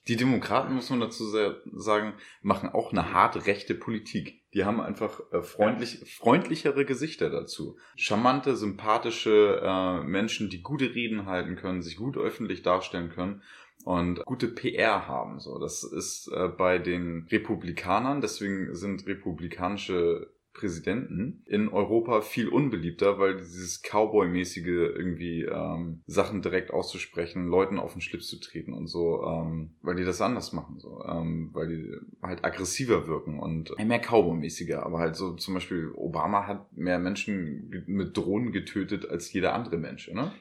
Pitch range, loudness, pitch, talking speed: 85-105 Hz, -29 LUFS, 90 Hz, 150 wpm